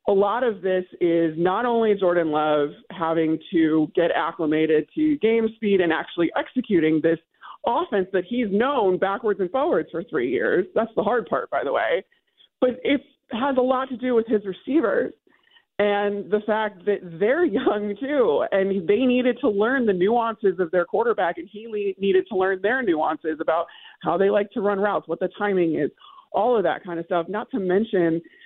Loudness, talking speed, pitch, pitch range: -23 LUFS, 190 wpm, 205 Hz, 180-250 Hz